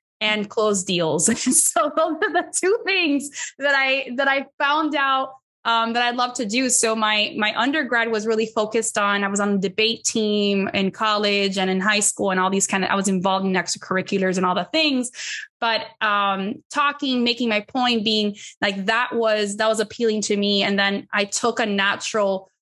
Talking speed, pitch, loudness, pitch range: 200 wpm, 220 Hz, -20 LUFS, 200-260 Hz